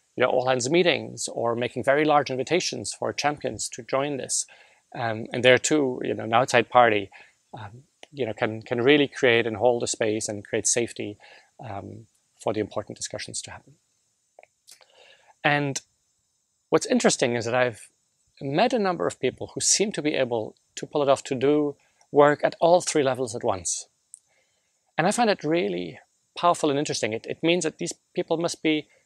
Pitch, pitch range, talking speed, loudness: 130 Hz, 115-150 Hz, 185 wpm, -24 LUFS